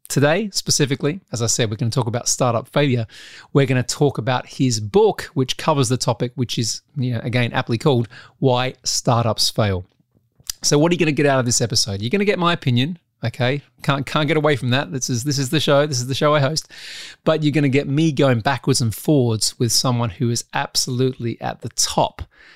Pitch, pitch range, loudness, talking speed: 130 Hz, 120-150 Hz, -19 LUFS, 230 wpm